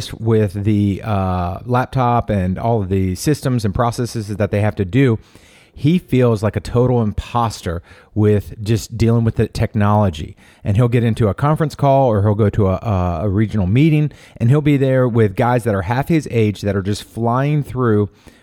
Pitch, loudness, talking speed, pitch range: 110 Hz, -17 LUFS, 190 wpm, 100-125 Hz